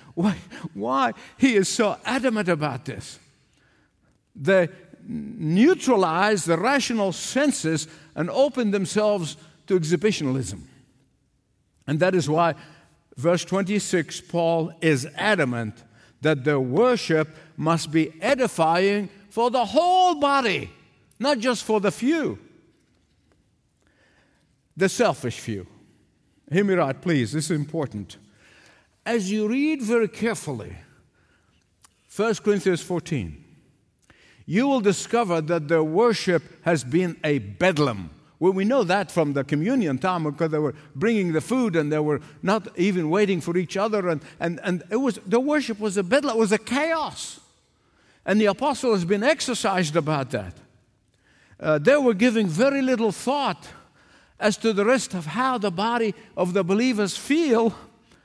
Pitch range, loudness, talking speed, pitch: 155-225 Hz, -23 LUFS, 140 wpm, 185 Hz